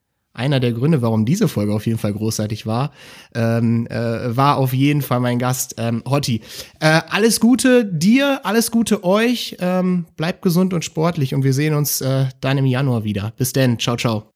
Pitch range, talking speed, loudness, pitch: 115-175 Hz, 190 wpm, -18 LUFS, 135 Hz